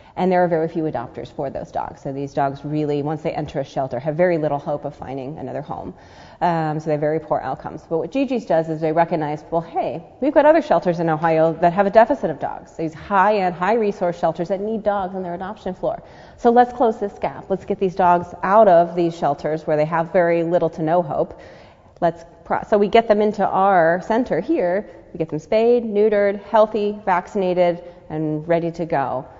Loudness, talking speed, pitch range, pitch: -20 LUFS, 220 wpm, 155-200 Hz, 175 Hz